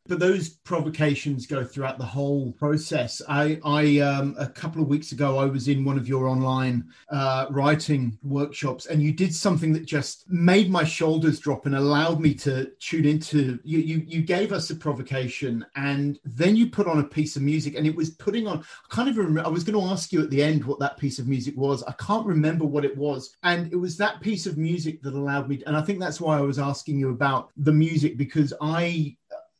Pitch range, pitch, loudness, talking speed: 140-165 Hz, 150 Hz, -25 LUFS, 225 wpm